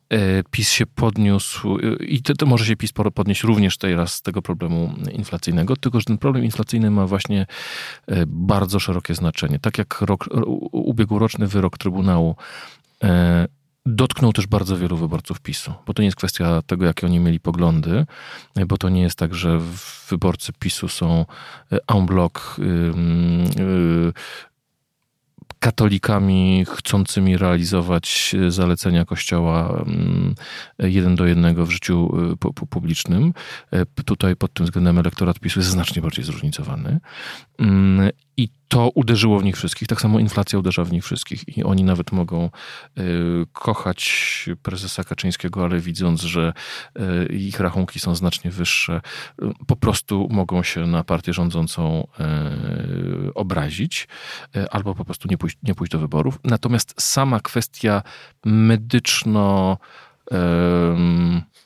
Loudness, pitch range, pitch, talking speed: -20 LUFS, 85-110 Hz, 95 Hz, 125 wpm